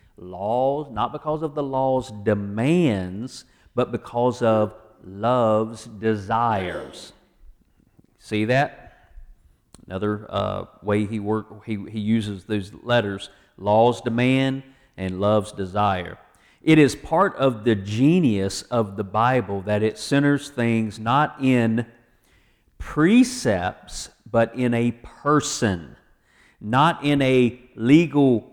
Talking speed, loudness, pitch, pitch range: 110 wpm, -22 LUFS, 115 Hz, 105-130 Hz